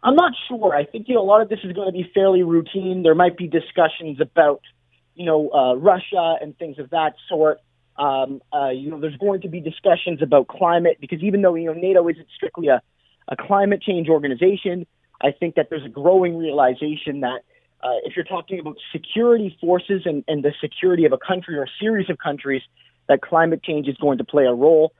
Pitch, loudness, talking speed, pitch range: 165 Hz, -20 LUFS, 220 wpm, 150-185 Hz